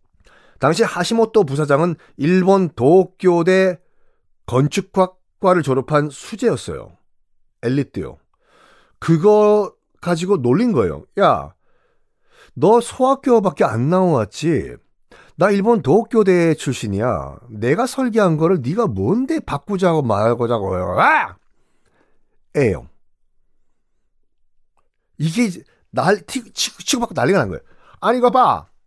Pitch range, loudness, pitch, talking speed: 145-225 Hz, -17 LUFS, 185 Hz, 220 characters per minute